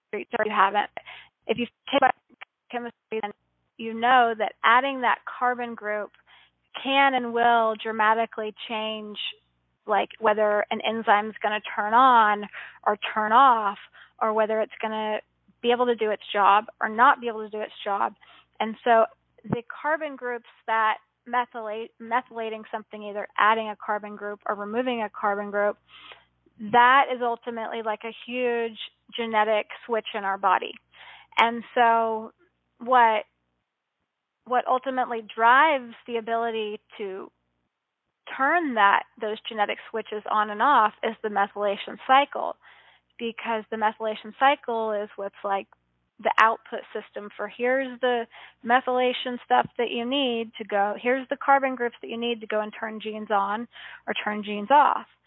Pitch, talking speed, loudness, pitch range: 225 Hz, 150 wpm, -24 LUFS, 210-240 Hz